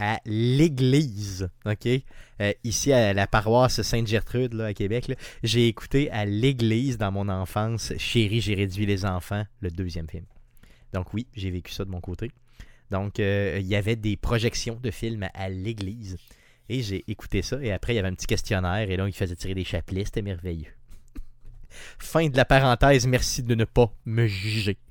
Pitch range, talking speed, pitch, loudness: 95-120 Hz, 190 wpm, 110 Hz, -25 LUFS